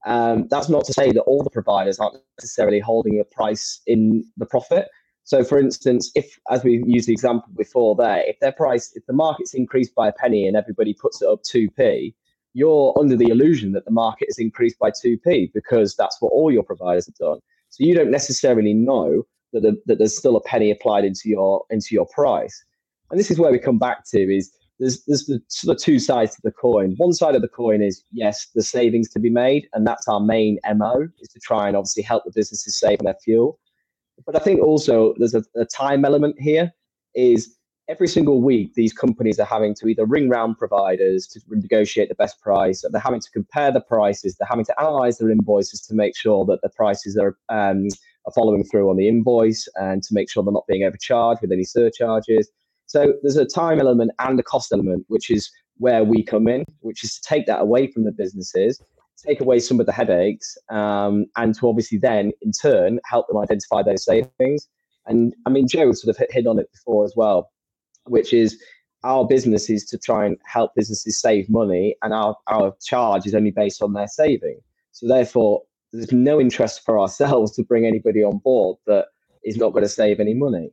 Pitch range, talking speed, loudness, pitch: 105-130 Hz, 215 wpm, -19 LUFS, 115 Hz